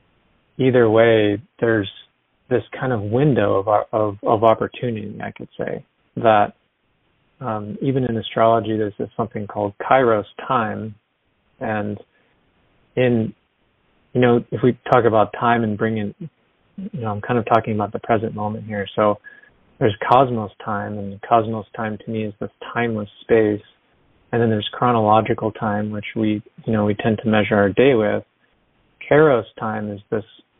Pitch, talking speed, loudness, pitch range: 110 Hz, 160 wpm, -20 LUFS, 105-120 Hz